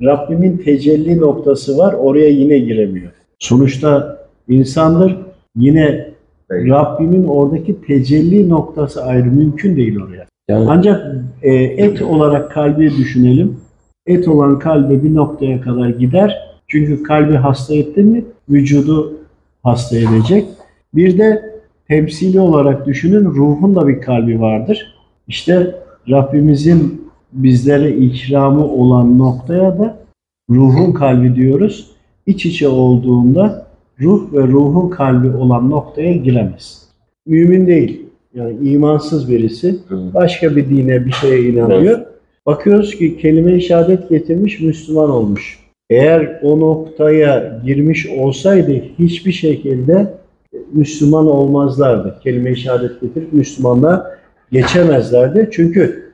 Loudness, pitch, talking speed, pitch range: -12 LUFS, 150 Hz, 110 wpm, 130-170 Hz